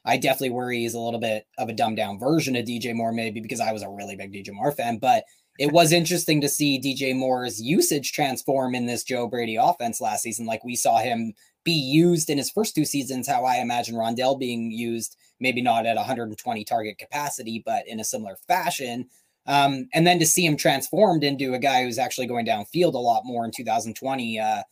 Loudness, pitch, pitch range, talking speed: -24 LUFS, 125 Hz, 115-145 Hz, 215 wpm